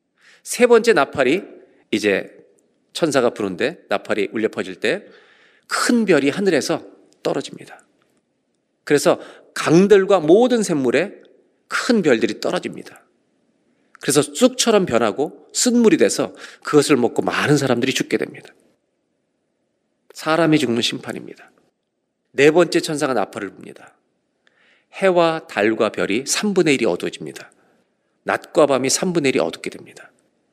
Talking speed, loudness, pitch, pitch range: 265 characters per minute, -18 LUFS, 185 Hz, 155-235 Hz